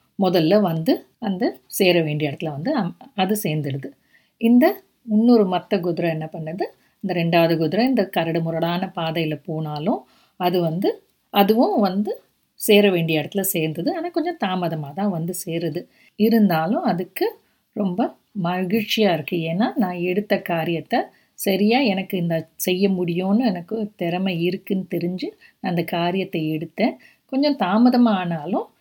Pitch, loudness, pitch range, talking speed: 185 Hz, -21 LUFS, 170-220 Hz, 130 wpm